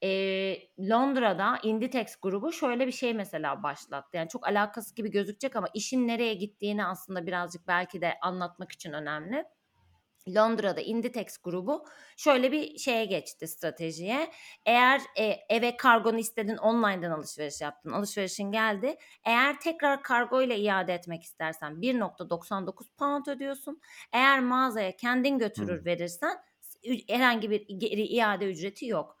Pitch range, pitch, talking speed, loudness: 185-250 Hz, 215 Hz, 125 wpm, -29 LUFS